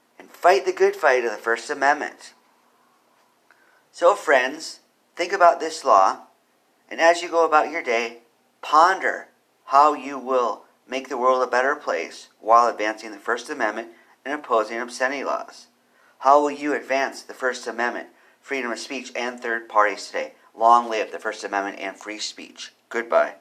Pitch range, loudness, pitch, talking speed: 115-145 Hz, -22 LUFS, 130 Hz, 160 wpm